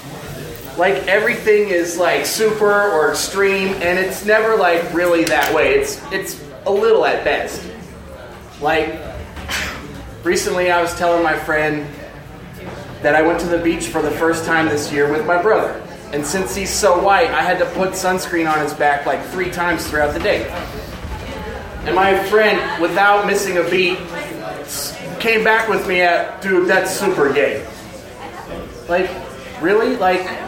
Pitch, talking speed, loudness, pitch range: 175 Hz, 160 wpm, -16 LUFS, 155-195 Hz